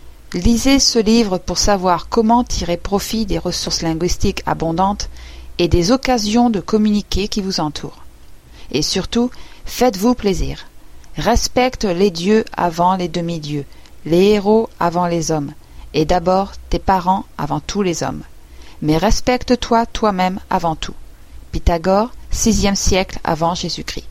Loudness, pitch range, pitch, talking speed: -17 LUFS, 165-215 Hz, 185 Hz, 130 wpm